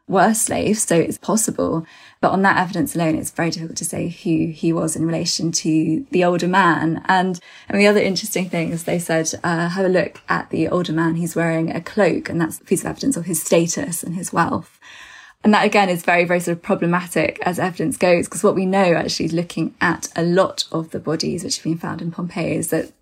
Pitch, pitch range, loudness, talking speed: 175 Hz, 165-190 Hz, -19 LUFS, 230 wpm